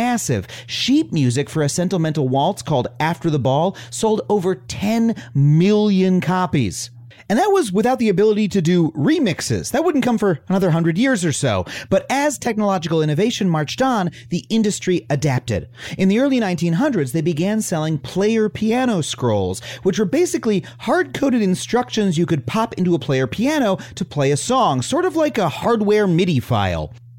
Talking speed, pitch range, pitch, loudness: 170 wpm, 145-220 Hz, 185 Hz, -19 LUFS